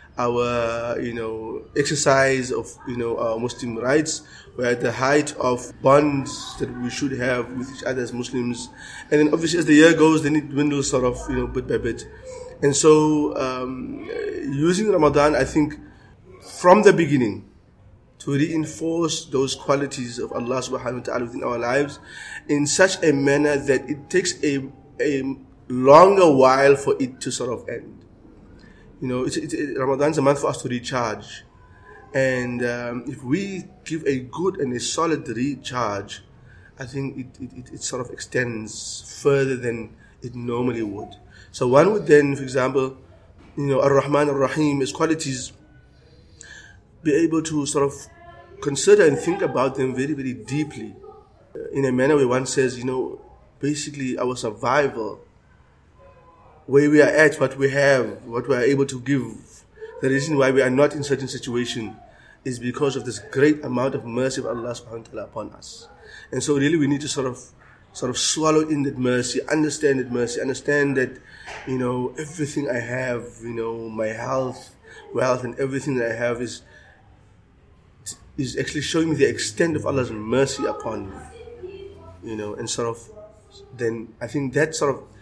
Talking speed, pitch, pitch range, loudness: 170 wpm, 130 Hz, 120-145 Hz, -21 LUFS